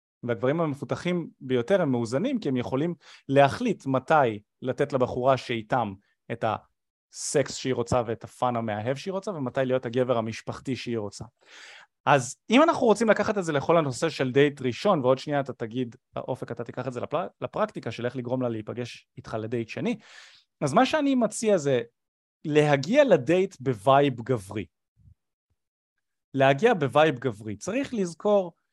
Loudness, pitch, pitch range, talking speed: -26 LUFS, 130 Hz, 120-165 Hz, 150 wpm